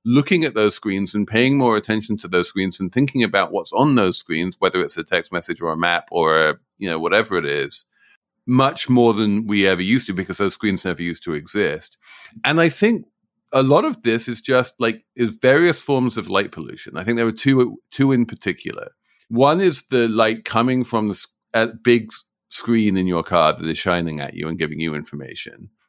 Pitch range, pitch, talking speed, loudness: 100-130 Hz, 115 Hz, 210 wpm, -19 LUFS